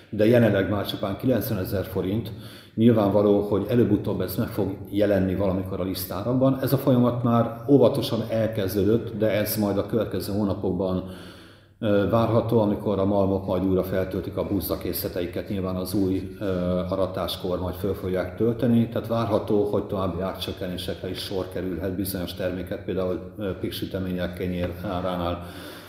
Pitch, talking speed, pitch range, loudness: 100 Hz, 140 wpm, 95-110 Hz, -25 LUFS